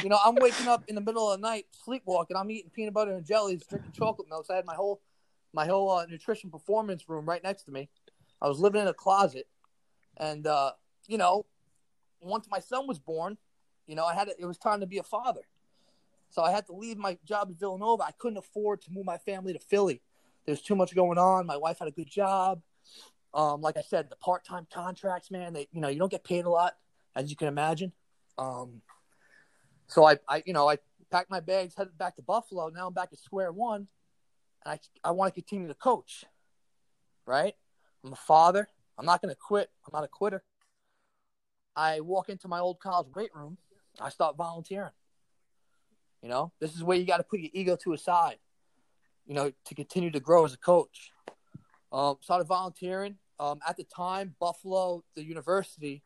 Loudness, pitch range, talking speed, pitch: -30 LUFS, 160-200 Hz, 210 wpm, 180 Hz